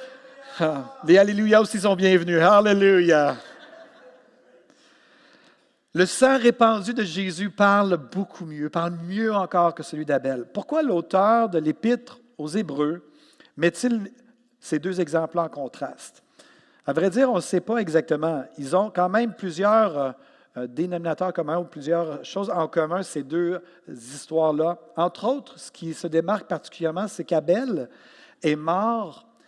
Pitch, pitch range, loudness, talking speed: 180 Hz, 165-220 Hz, -23 LUFS, 135 wpm